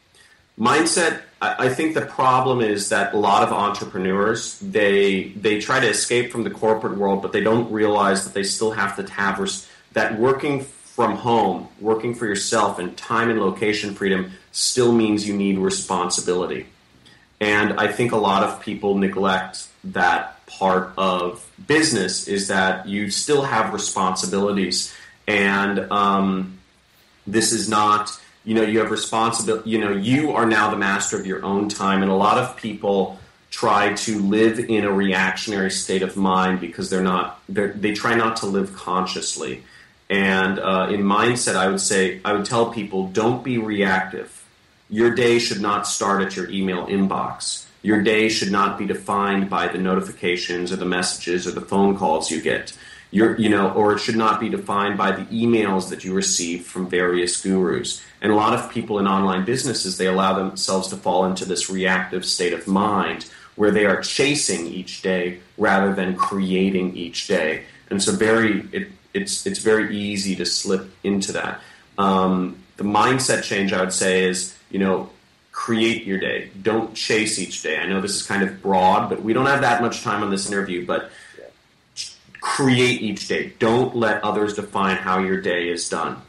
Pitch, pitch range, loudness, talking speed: 100 Hz, 95-110 Hz, -20 LUFS, 180 wpm